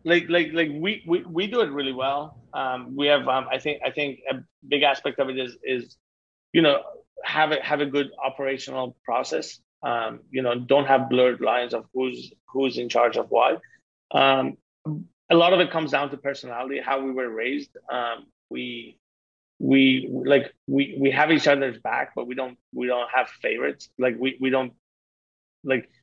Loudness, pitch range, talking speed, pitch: -24 LUFS, 125-145 Hz, 190 wpm, 135 Hz